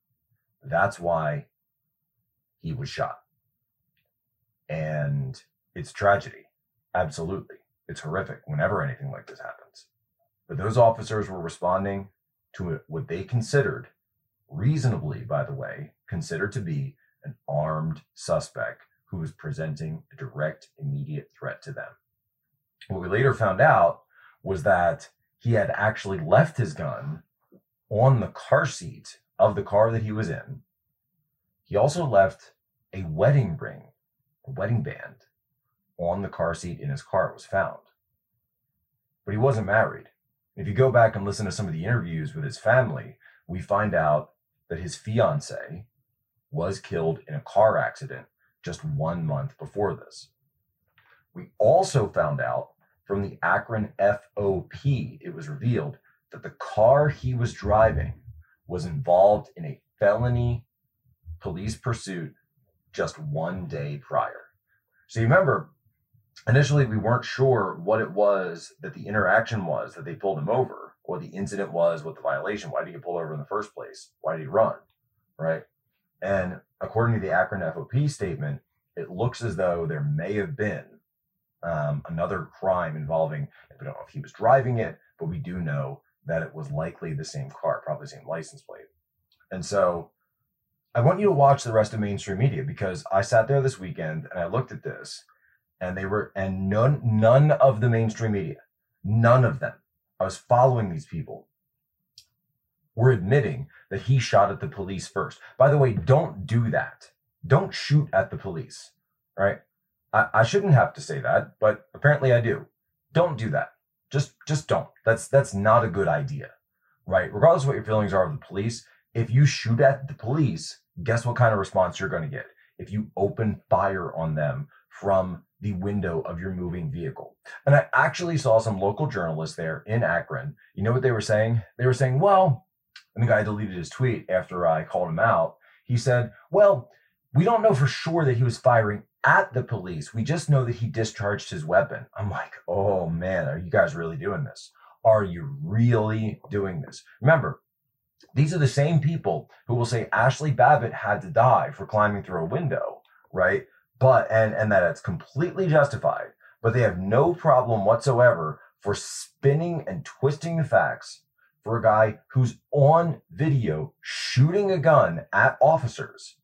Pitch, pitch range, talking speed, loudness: 120 Hz, 100-140 Hz, 170 wpm, -24 LUFS